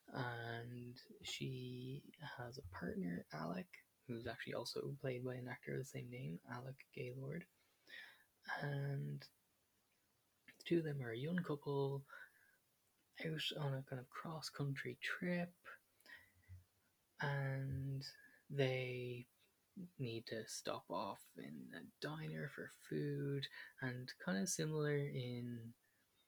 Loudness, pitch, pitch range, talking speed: -46 LUFS, 130 Hz, 115-140 Hz, 115 wpm